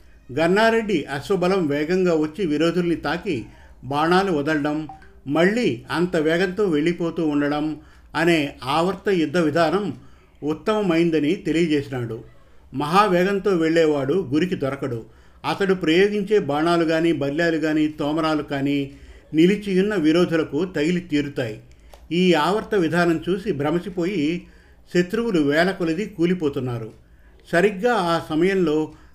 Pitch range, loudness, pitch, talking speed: 150-180 Hz, -21 LUFS, 165 Hz, 95 wpm